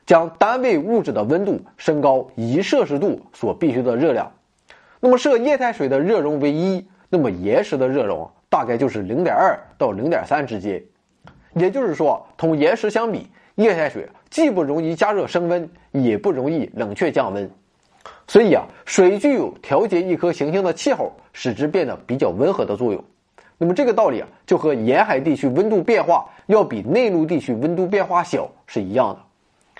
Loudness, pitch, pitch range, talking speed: -19 LUFS, 175 Hz, 150-210 Hz, 275 characters per minute